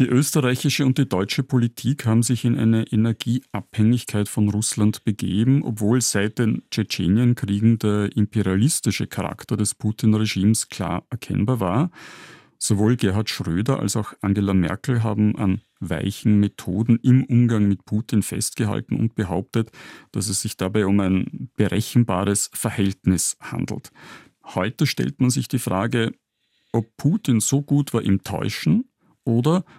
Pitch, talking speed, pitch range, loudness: 110 Hz, 135 wpm, 100-125 Hz, -21 LUFS